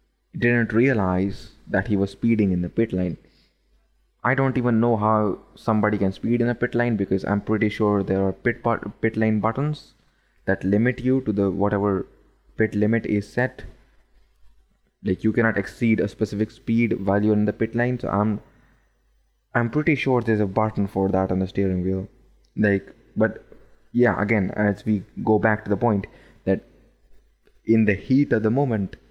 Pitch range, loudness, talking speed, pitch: 100-115 Hz, -23 LUFS, 180 wpm, 110 Hz